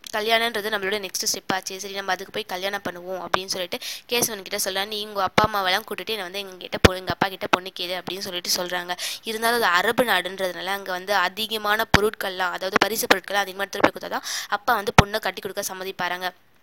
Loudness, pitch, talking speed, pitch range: -23 LUFS, 195 Hz, 190 wpm, 185-210 Hz